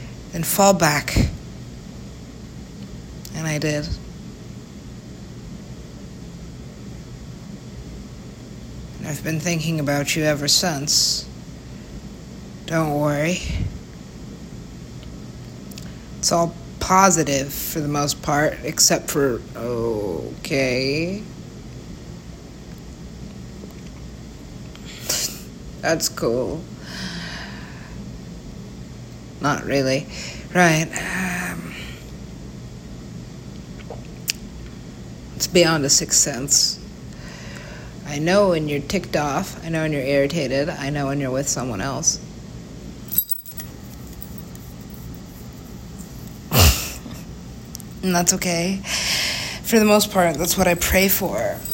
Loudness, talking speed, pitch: -20 LUFS, 80 wpm, 145 Hz